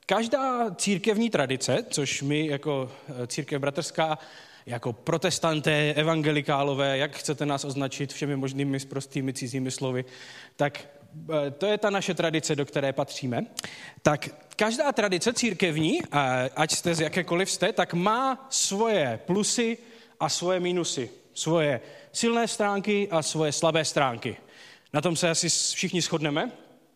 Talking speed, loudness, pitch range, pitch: 130 wpm, -27 LUFS, 140-190 Hz, 155 Hz